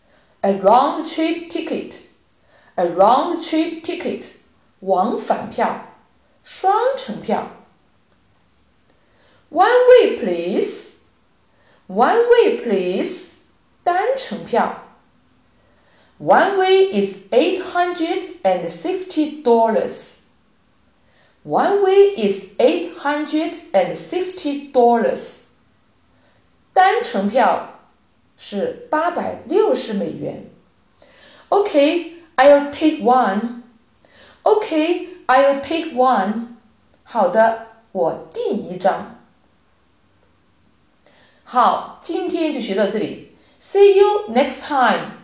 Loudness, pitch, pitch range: -18 LUFS, 320 Hz, 235-370 Hz